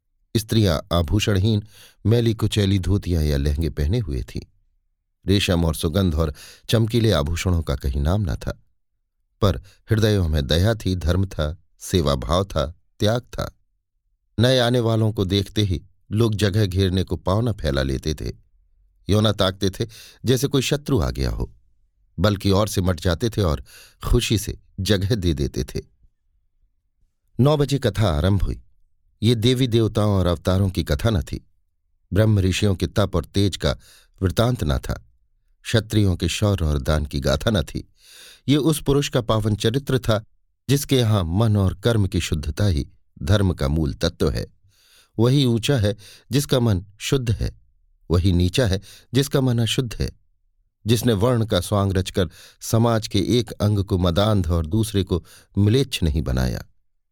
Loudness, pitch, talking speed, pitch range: -21 LUFS, 100 Hz, 165 wpm, 85-110 Hz